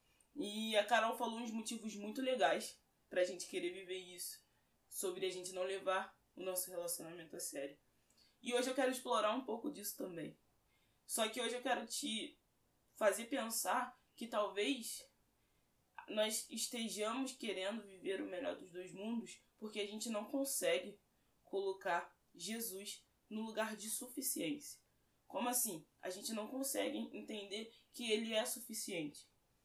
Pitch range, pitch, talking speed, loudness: 190-245 Hz, 220 Hz, 150 wpm, -41 LUFS